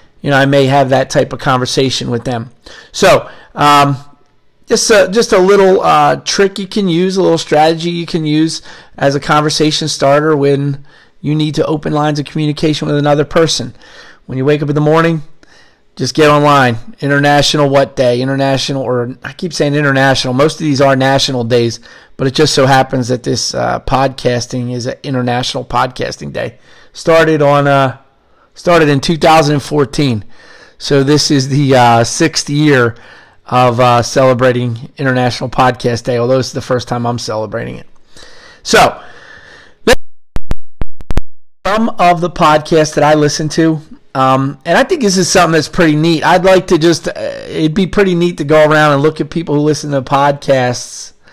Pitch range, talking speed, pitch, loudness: 130-155 Hz, 175 wpm, 145 Hz, -11 LUFS